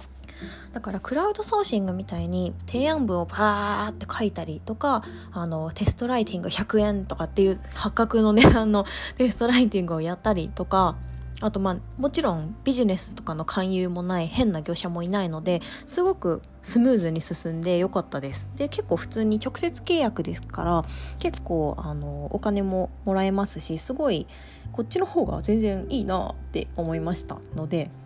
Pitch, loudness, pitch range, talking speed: 195 Hz, -24 LUFS, 165-235 Hz, 355 characters per minute